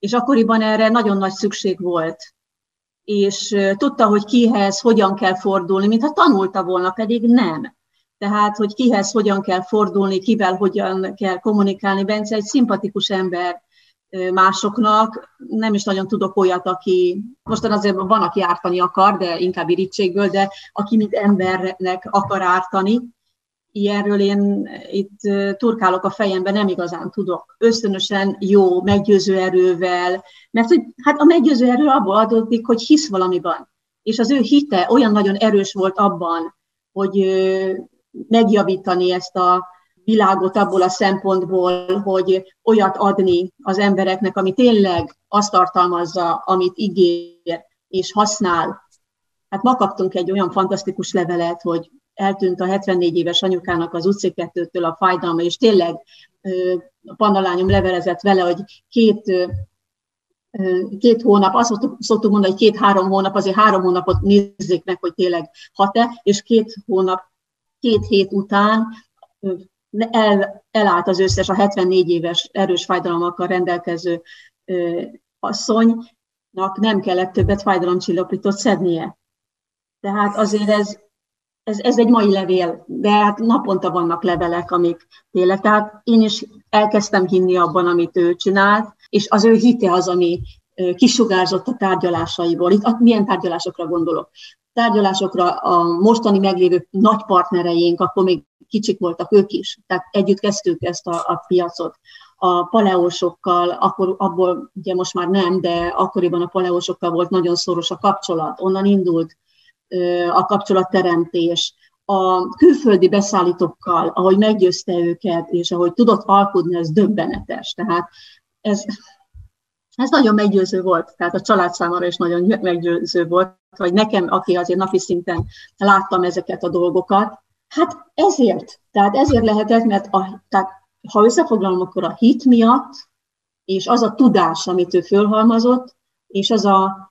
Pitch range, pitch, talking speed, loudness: 180-210 Hz, 195 Hz, 135 wpm, -17 LUFS